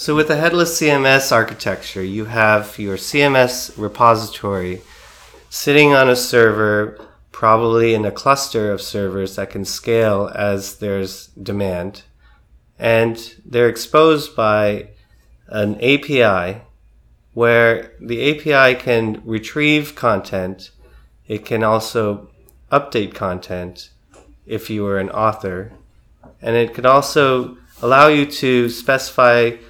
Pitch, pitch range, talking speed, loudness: 110 Hz, 100-125 Hz, 115 wpm, -16 LUFS